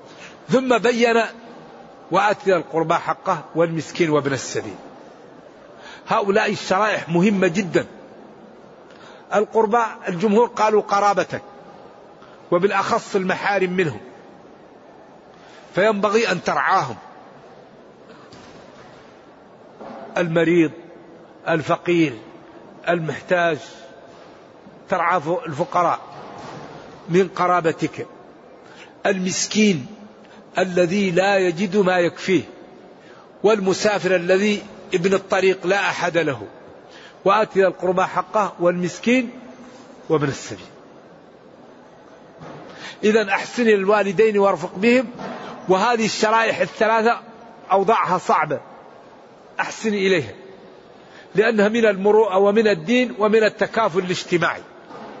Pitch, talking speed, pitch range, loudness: 195 Hz, 75 wpm, 175-220 Hz, -19 LUFS